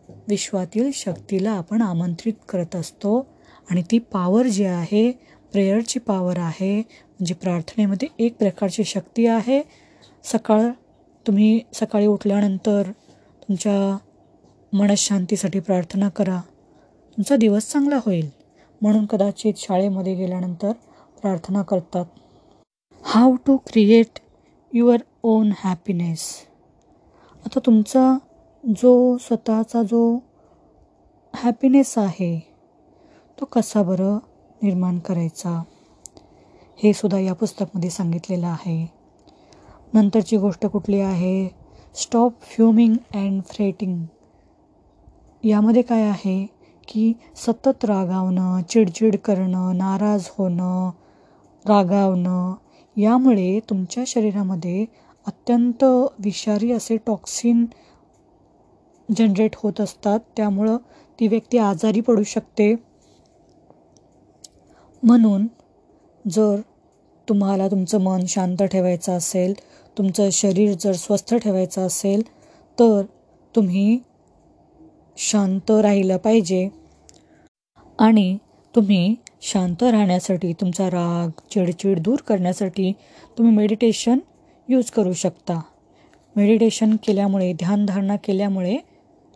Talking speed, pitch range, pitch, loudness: 90 wpm, 190-230 Hz, 210 Hz, -20 LUFS